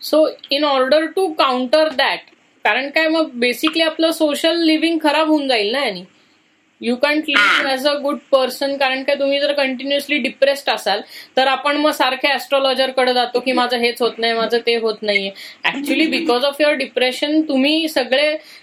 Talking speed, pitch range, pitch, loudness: 170 wpm, 255-305 Hz, 280 Hz, -17 LUFS